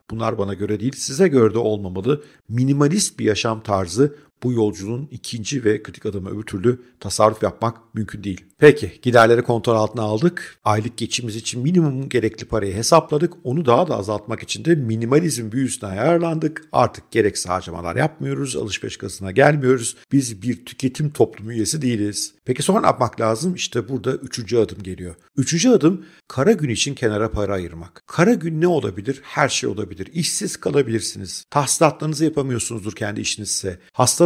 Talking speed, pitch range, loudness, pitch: 160 wpm, 105-145 Hz, -20 LUFS, 120 Hz